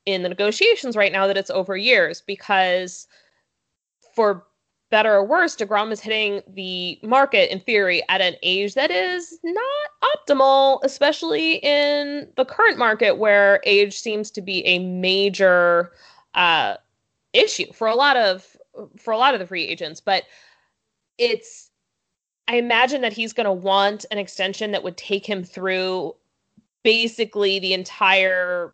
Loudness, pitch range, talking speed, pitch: -19 LUFS, 190-270 Hz, 150 wpm, 205 Hz